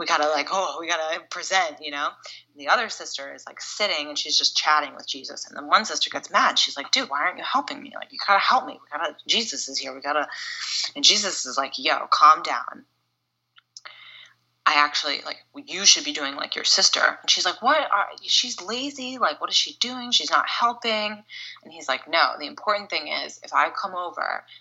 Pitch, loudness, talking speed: 210 Hz, -22 LUFS, 225 wpm